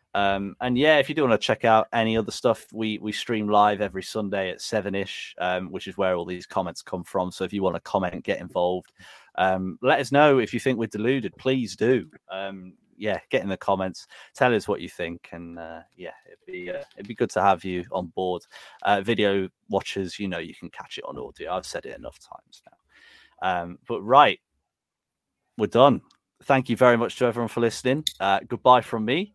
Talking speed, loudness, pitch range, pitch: 225 wpm, -24 LUFS, 95-120 Hz, 105 Hz